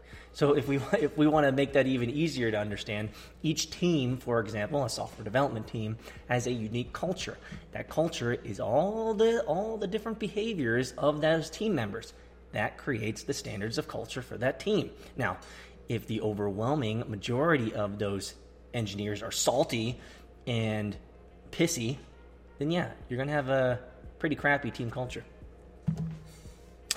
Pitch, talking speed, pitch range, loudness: 125 Hz, 155 wpm, 110-150 Hz, -31 LUFS